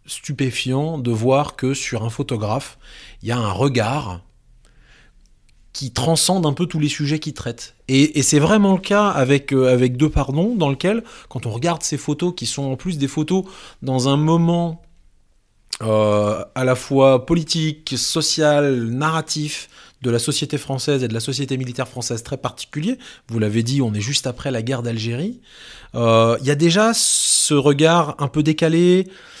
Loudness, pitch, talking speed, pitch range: -19 LUFS, 140 Hz, 180 wpm, 120-160 Hz